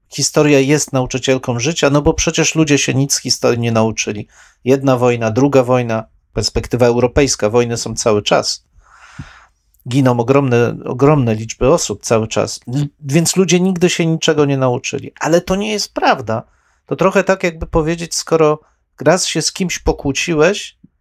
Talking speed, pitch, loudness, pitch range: 155 wpm, 140 Hz, -15 LUFS, 125-160 Hz